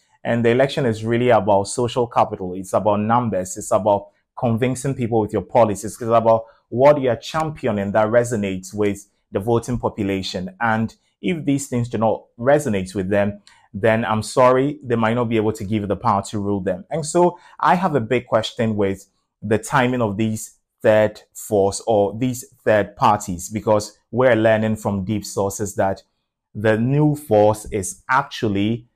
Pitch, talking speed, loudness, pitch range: 110 Hz, 175 wpm, -20 LUFS, 100-125 Hz